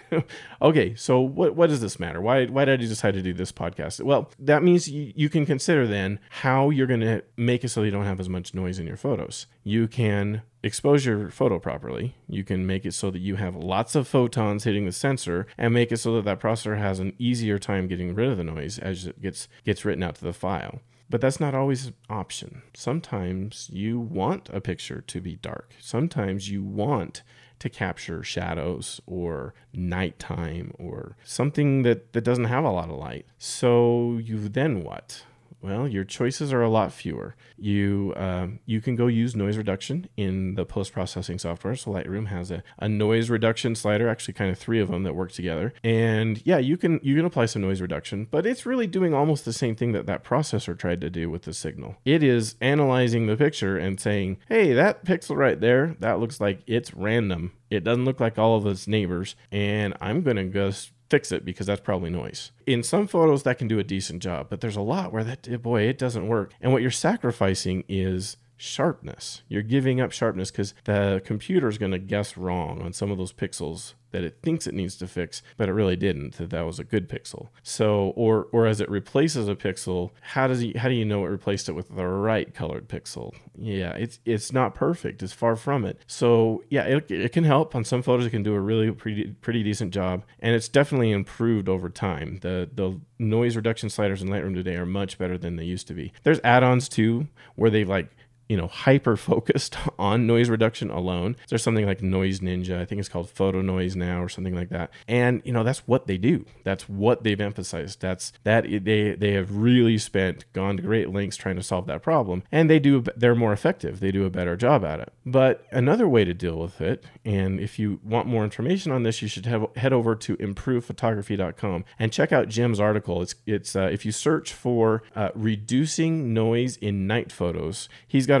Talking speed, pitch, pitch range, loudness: 215 wpm, 110 Hz, 95-120 Hz, -25 LUFS